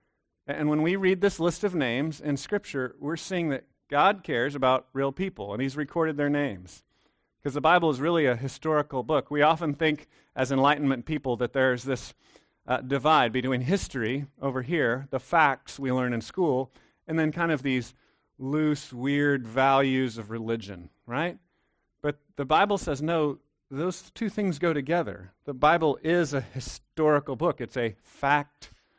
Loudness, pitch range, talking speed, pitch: -27 LUFS, 130-160 Hz, 170 wpm, 145 Hz